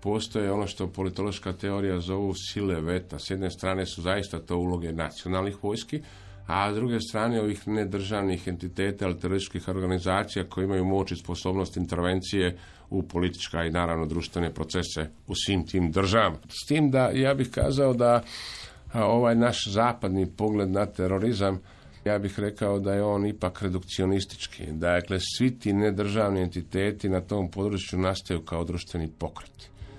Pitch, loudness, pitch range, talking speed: 95 Hz, -28 LUFS, 90-105 Hz, 150 wpm